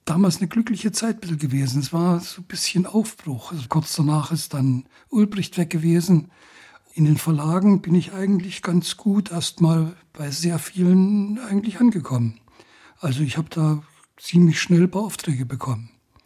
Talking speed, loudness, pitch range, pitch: 150 wpm, -21 LUFS, 150-190 Hz, 170 Hz